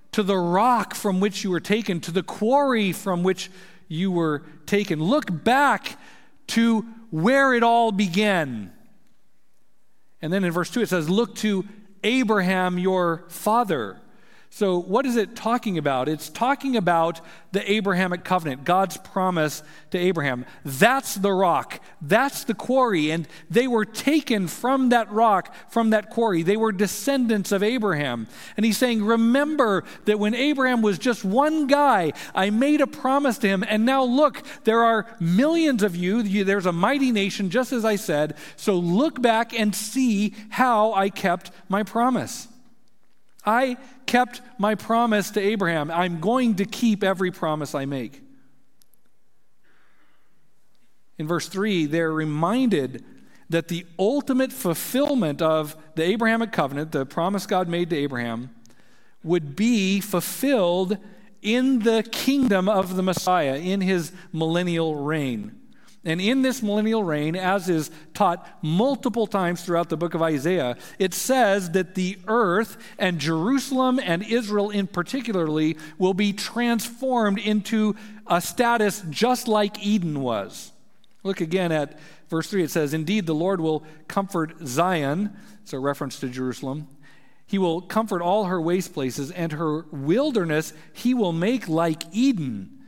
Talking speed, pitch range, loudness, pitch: 150 wpm, 170-230 Hz, -23 LUFS, 200 Hz